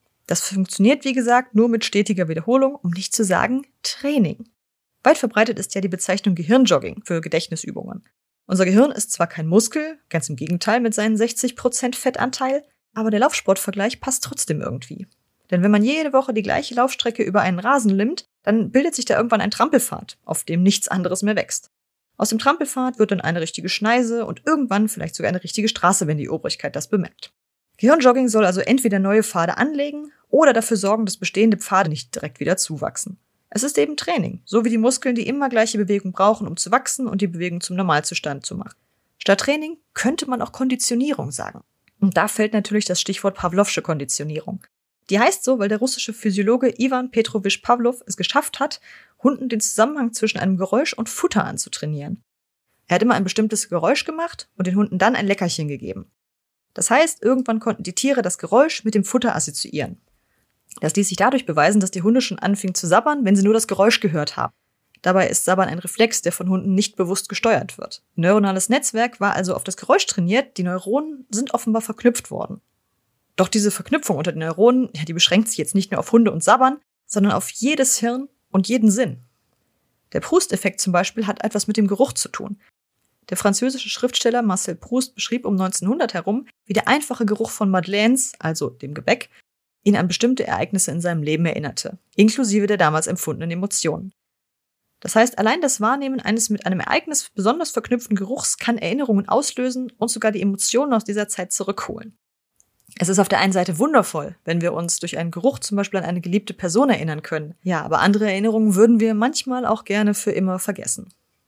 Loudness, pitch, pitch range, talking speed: -20 LUFS, 210 Hz, 185-245 Hz, 190 wpm